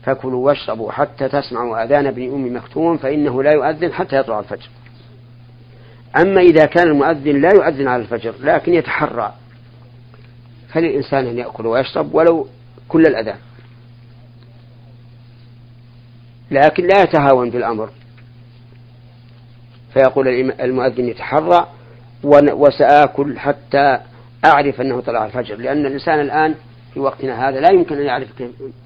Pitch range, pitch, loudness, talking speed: 120-145 Hz, 125 Hz, -15 LUFS, 115 wpm